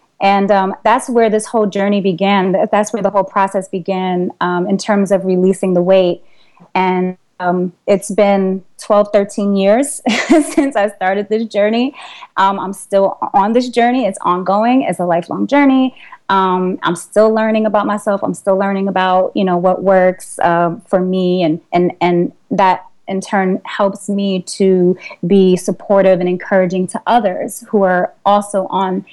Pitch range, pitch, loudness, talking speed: 185-205 Hz, 195 Hz, -14 LUFS, 165 wpm